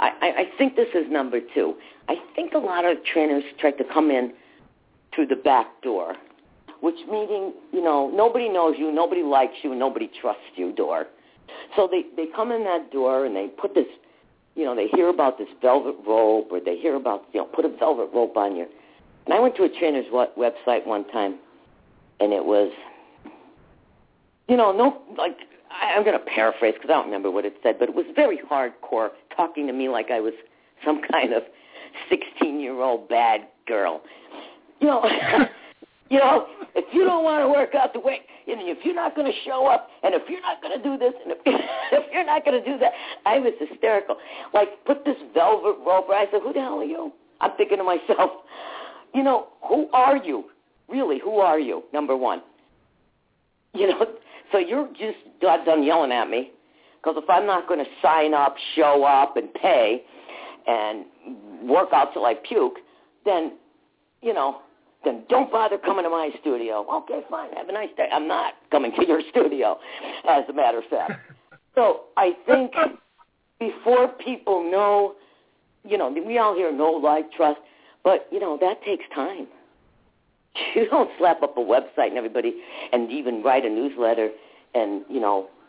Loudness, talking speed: -23 LUFS, 190 wpm